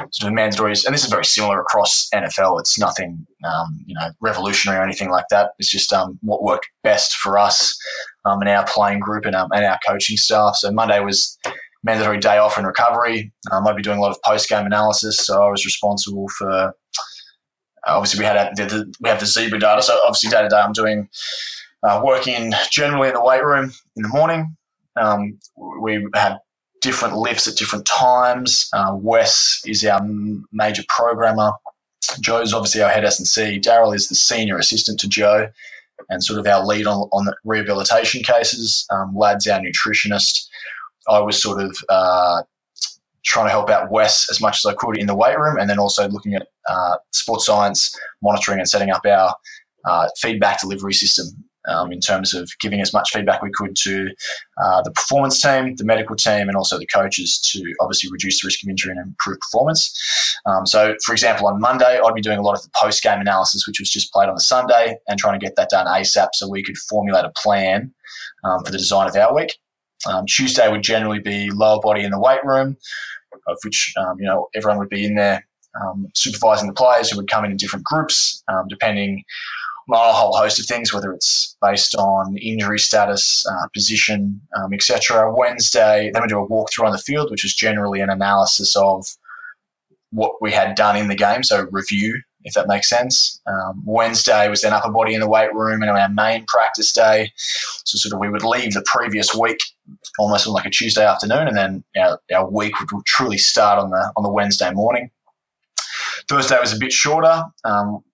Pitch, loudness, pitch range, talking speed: 105 Hz, -17 LUFS, 100-110 Hz, 205 wpm